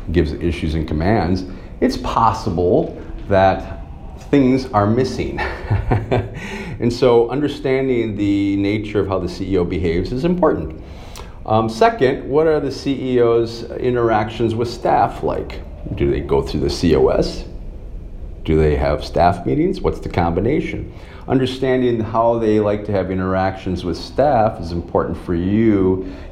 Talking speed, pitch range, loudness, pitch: 135 wpm, 85-120 Hz, -18 LUFS, 105 Hz